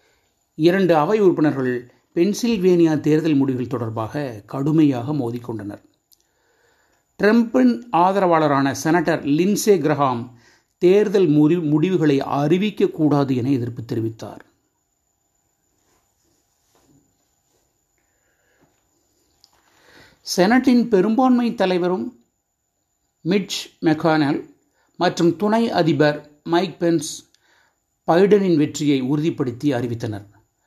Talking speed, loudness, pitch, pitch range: 70 wpm, -19 LUFS, 155 Hz, 135-185 Hz